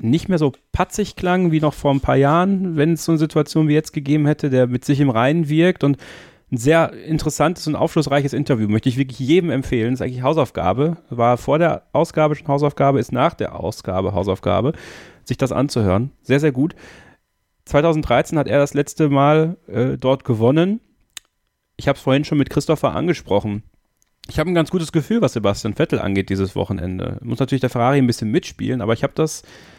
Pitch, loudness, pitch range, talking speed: 140 Hz, -19 LUFS, 120-155 Hz, 200 wpm